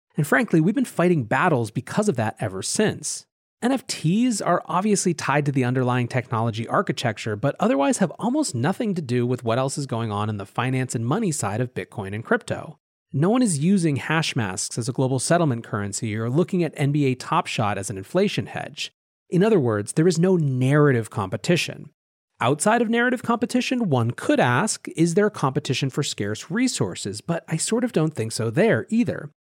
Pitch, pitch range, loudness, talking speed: 150 Hz, 125-185 Hz, -23 LUFS, 190 wpm